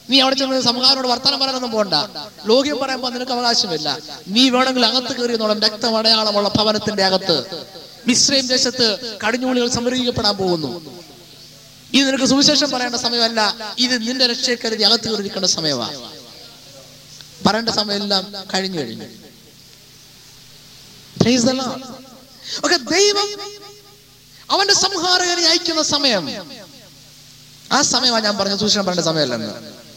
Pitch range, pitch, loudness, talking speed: 190-260 Hz, 230 Hz, -16 LUFS, 90 wpm